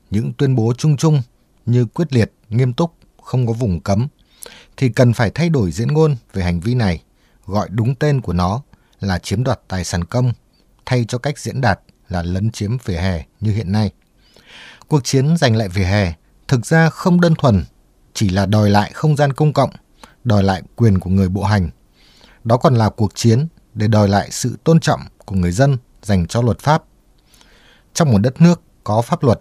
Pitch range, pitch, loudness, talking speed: 100-135 Hz, 115 Hz, -17 LUFS, 205 wpm